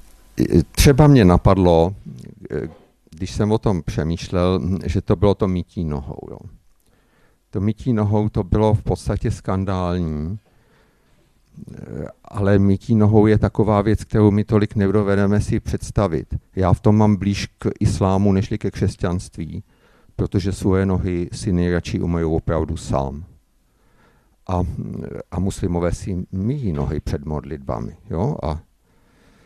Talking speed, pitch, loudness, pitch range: 130 wpm, 95 Hz, -20 LUFS, 90-105 Hz